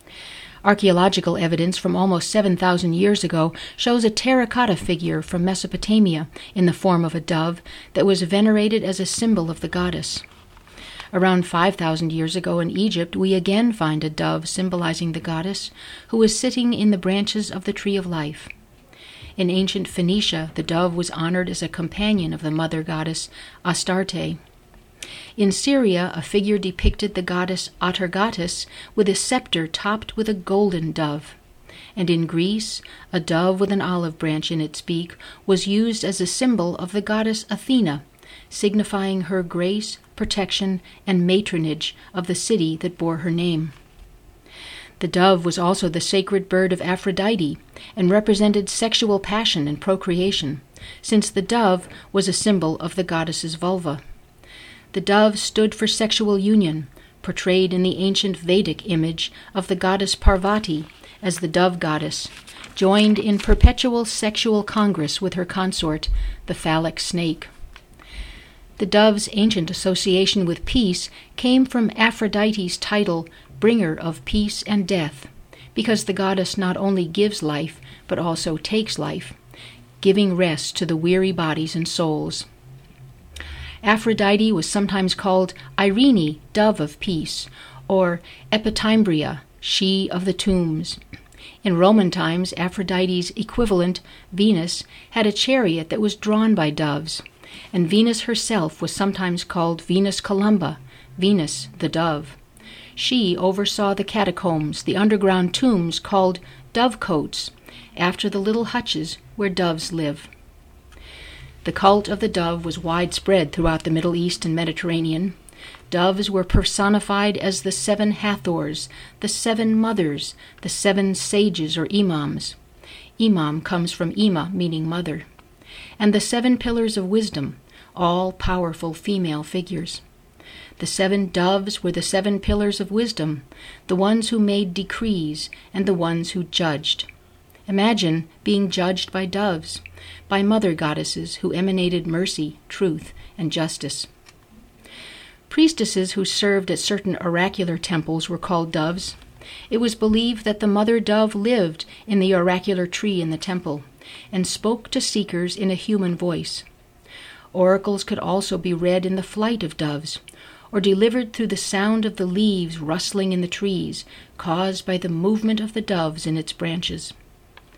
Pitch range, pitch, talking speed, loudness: 165-205 Hz, 185 Hz, 145 wpm, -21 LUFS